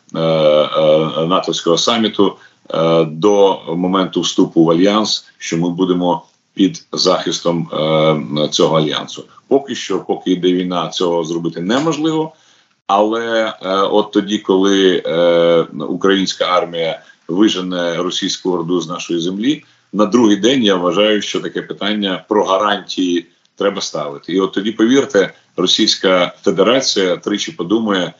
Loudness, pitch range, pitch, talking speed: -15 LUFS, 85-105 Hz, 90 Hz, 115 wpm